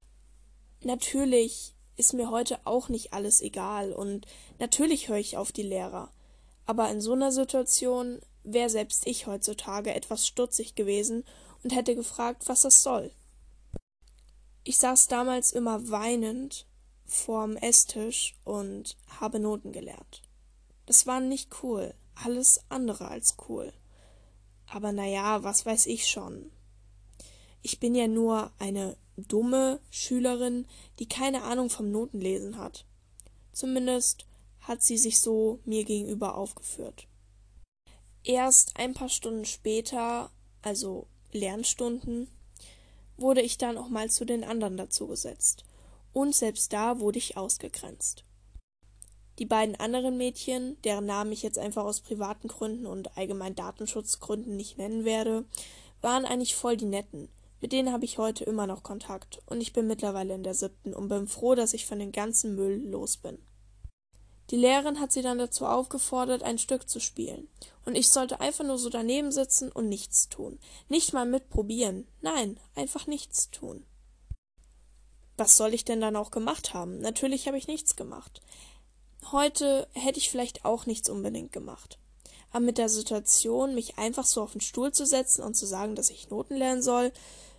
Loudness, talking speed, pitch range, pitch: -27 LUFS, 150 wpm, 195-250 Hz, 220 Hz